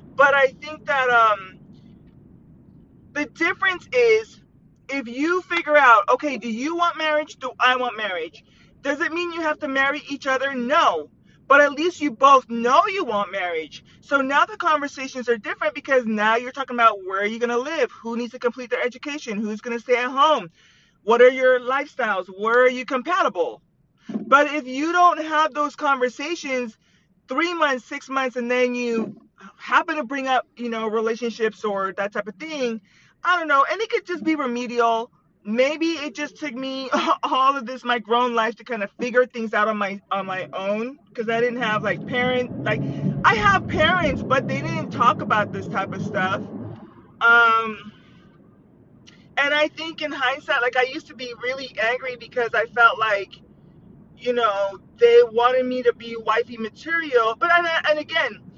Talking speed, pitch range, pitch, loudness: 185 wpm, 230-295 Hz, 255 Hz, -21 LUFS